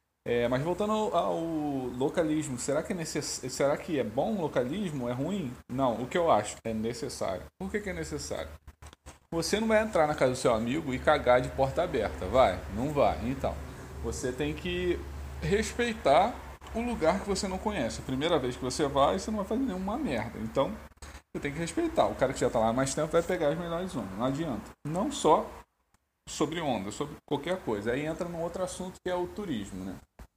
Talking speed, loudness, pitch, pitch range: 215 wpm, -30 LUFS, 160 Hz, 125-185 Hz